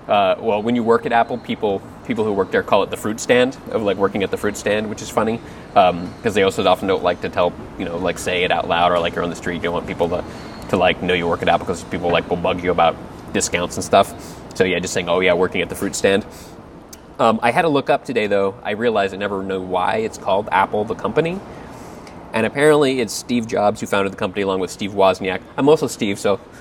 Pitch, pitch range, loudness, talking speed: 100 Hz, 95-115 Hz, -19 LUFS, 265 wpm